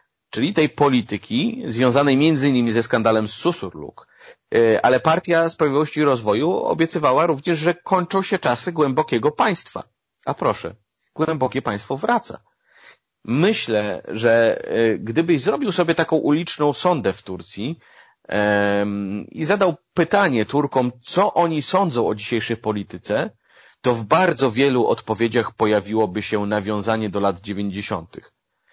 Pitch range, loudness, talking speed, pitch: 110-165 Hz, -20 LUFS, 120 wpm, 130 Hz